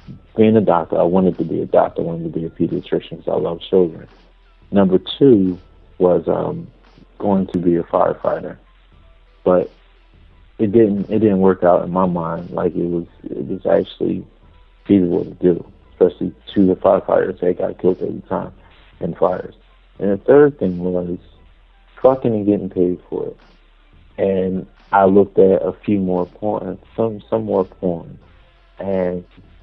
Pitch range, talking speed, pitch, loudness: 85-100 Hz, 165 wpm, 95 Hz, -18 LUFS